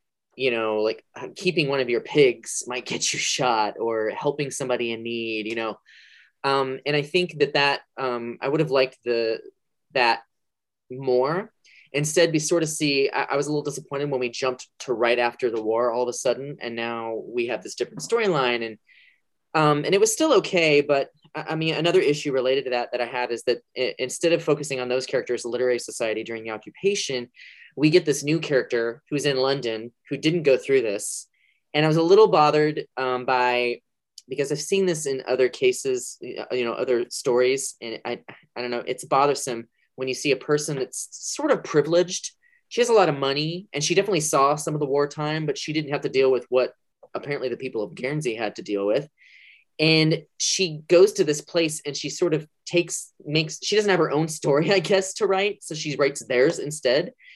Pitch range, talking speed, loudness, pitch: 125-165 Hz, 210 wpm, -23 LUFS, 145 Hz